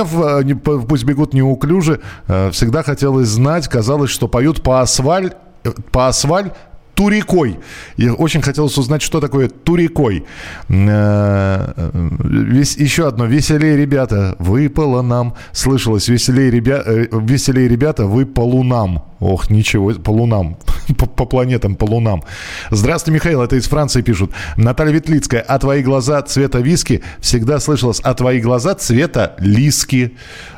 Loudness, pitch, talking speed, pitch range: -14 LUFS, 130 Hz, 125 wpm, 115-145 Hz